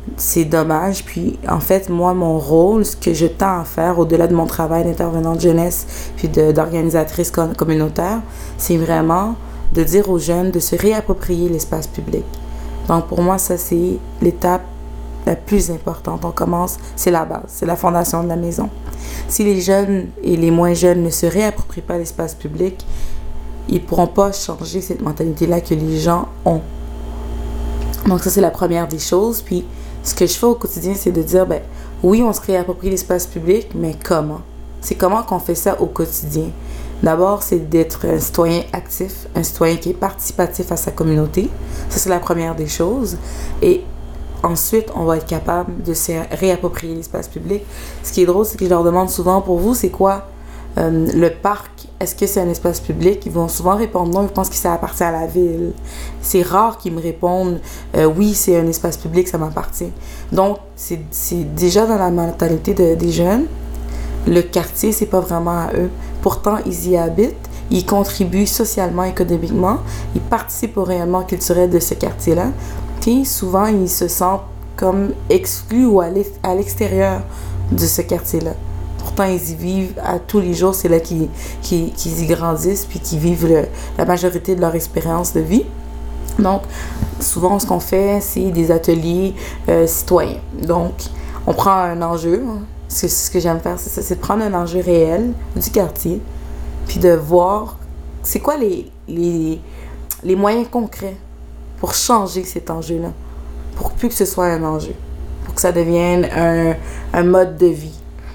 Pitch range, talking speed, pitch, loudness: 160-185 Hz, 180 wpm, 175 Hz, -17 LUFS